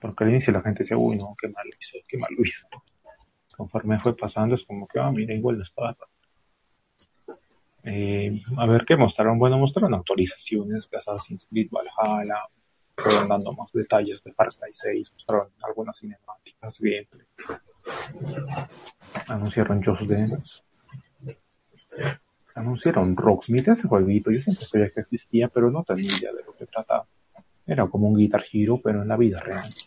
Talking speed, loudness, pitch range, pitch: 165 wpm, -24 LUFS, 105-125 Hz, 110 Hz